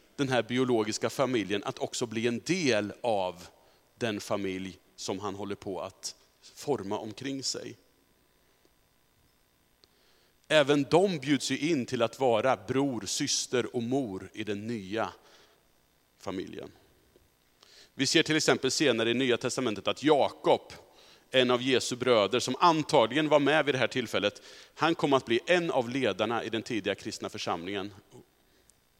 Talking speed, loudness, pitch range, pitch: 145 wpm, -29 LUFS, 105-140 Hz, 125 Hz